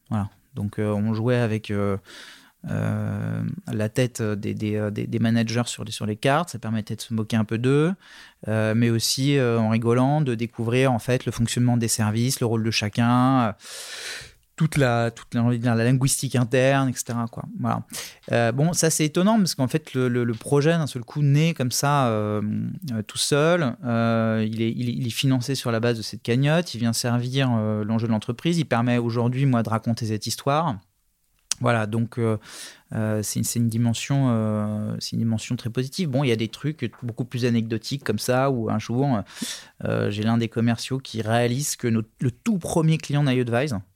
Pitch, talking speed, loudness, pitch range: 120 Hz, 200 wpm, -23 LUFS, 110-130 Hz